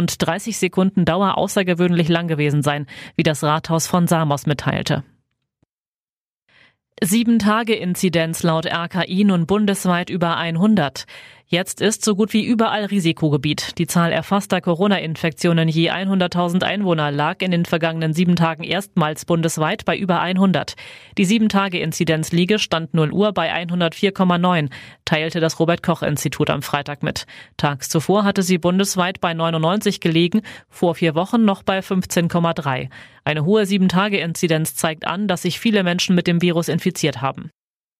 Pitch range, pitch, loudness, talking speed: 160-190 Hz, 175 Hz, -19 LUFS, 140 wpm